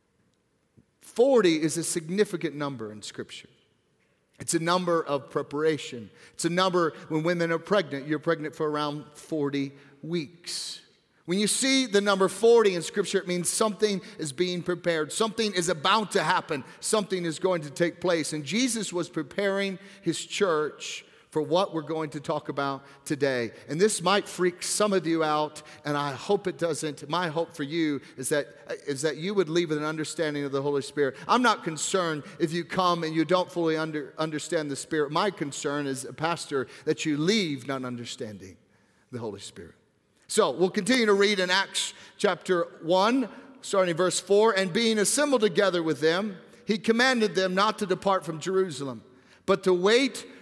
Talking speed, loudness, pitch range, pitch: 180 wpm, -26 LUFS, 150-200 Hz, 170 Hz